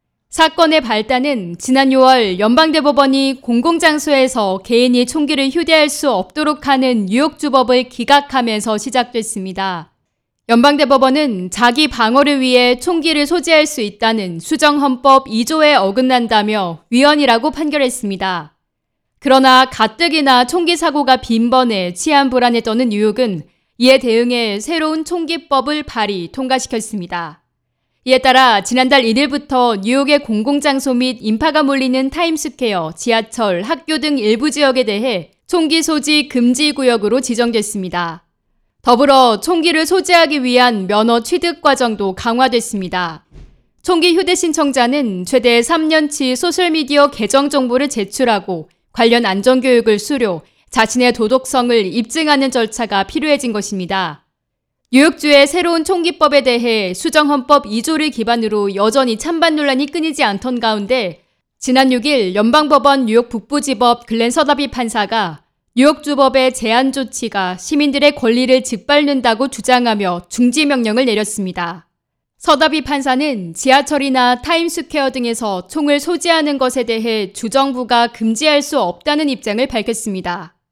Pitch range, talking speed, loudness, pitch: 220-290 Hz, 315 characters per minute, -14 LUFS, 255 Hz